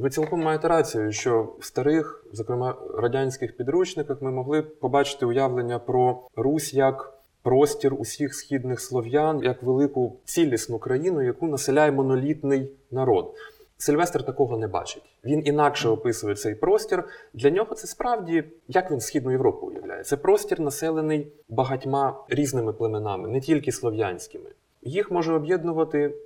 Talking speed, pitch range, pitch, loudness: 135 wpm, 130-165 Hz, 145 Hz, -25 LUFS